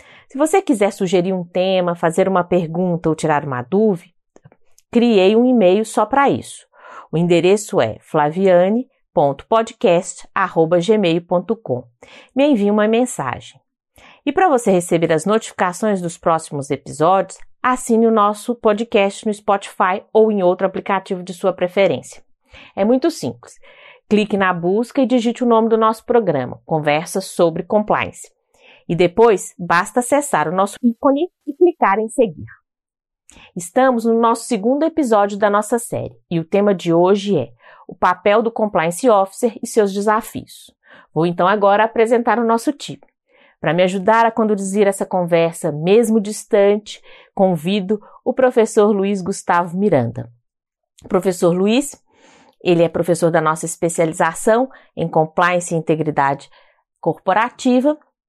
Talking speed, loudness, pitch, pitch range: 135 wpm, -17 LUFS, 200 Hz, 175-235 Hz